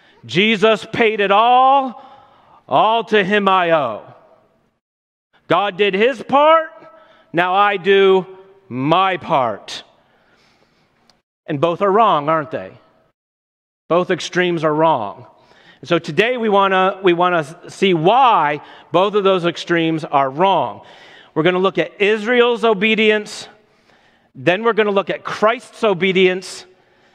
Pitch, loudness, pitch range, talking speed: 195 Hz, -16 LUFS, 170-220 Hz, 125 wpm